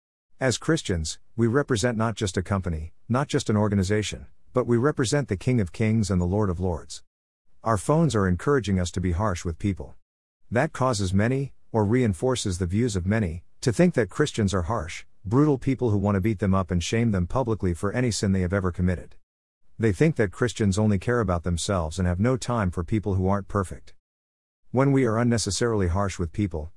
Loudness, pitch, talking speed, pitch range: -25 LUFS, 105 Hz, 205 wpm, 90-120 Hz